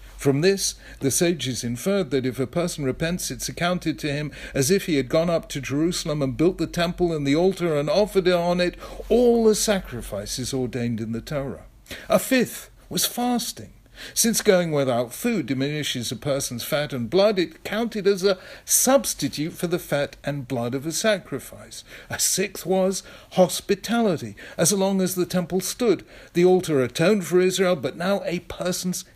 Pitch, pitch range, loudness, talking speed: 170 Hz, 135-190 Hz, -23 LUFS, 175 wpm